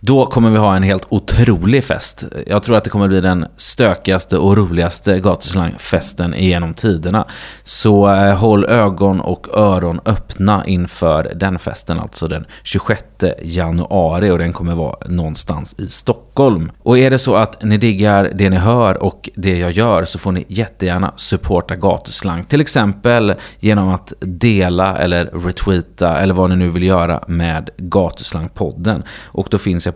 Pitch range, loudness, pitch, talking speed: 90-105 Hz, -14 LUFS, 95 Hz, 160 wpm